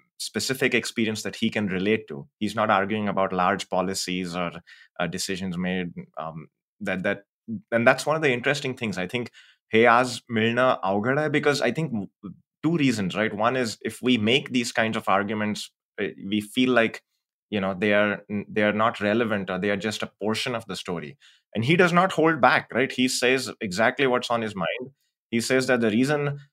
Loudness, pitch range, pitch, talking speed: -24 LUFS, 100-130 Hz, 110 Hz, 195 wpm